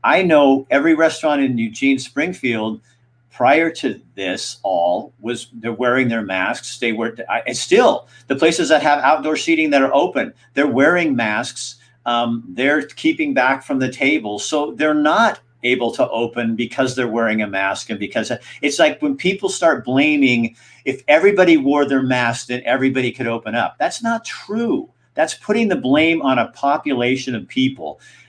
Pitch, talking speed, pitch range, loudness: 135 Hz, 170 wpm, 120-155 Hz, -17 LUFS